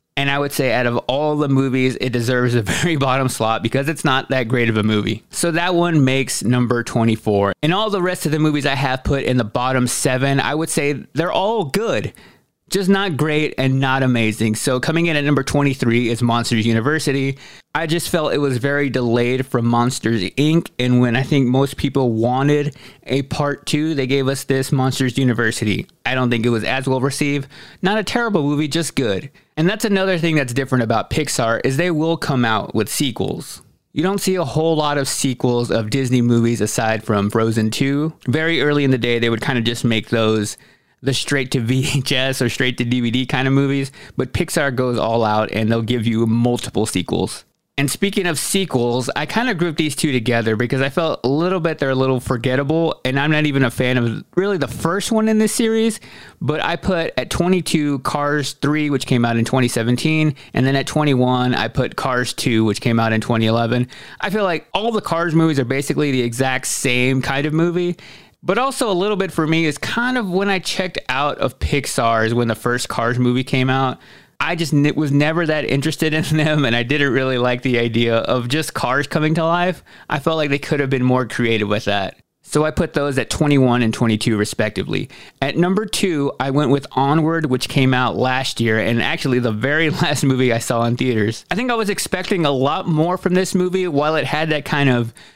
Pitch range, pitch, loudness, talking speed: 120-155 Hz, 135 Hz, -18 LUFS, 220 wpm